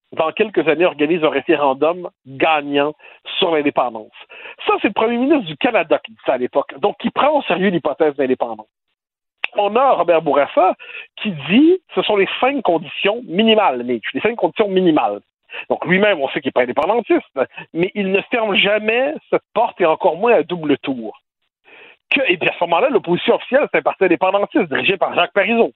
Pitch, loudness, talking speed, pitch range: 185 Hz, -17 LUFS, 190 wpm, 150-225 Hz